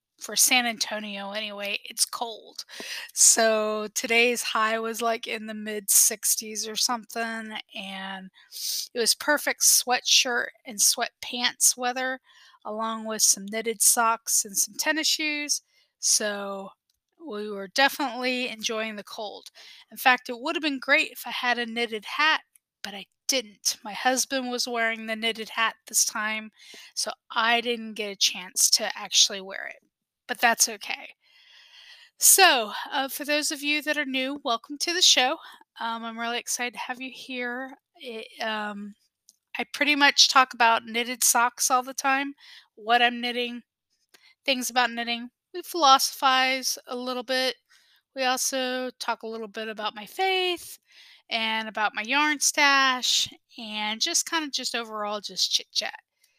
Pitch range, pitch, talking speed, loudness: 220-270 Hz, 240 Hz, 155 wpm, -23 LUFS